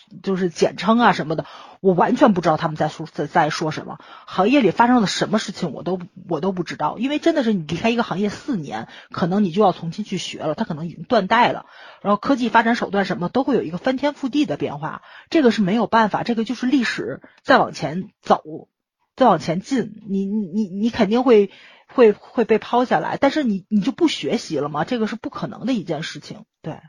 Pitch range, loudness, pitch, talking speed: 175-235 Hz, -20 LUFS, 210 Hz, 335 characters per minute